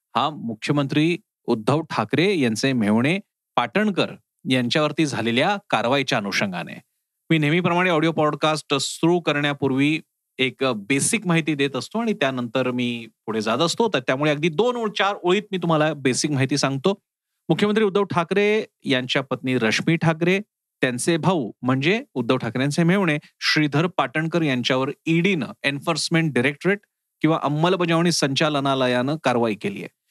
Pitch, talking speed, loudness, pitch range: 155 Hz, 130 wpm, -21 LUFS, 135-175 Hz